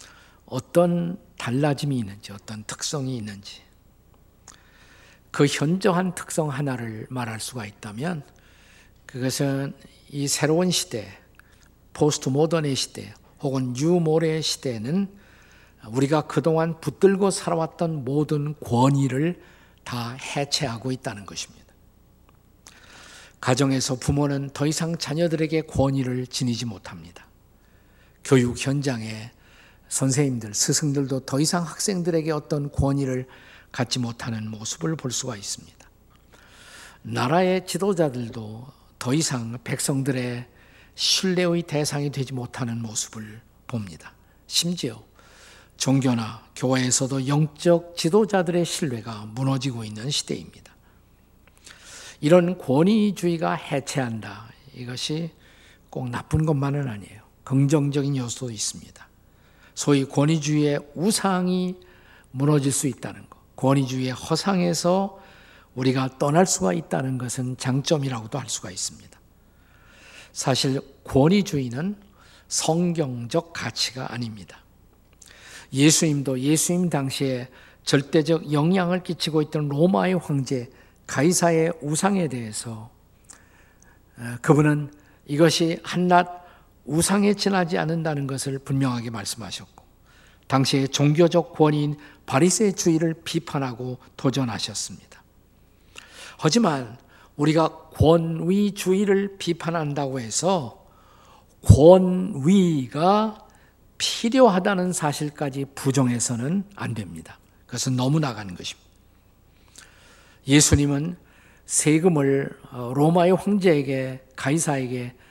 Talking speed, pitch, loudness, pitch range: 250 characters per minute, 140 Hz, -23 LUFS, 120-165 Hz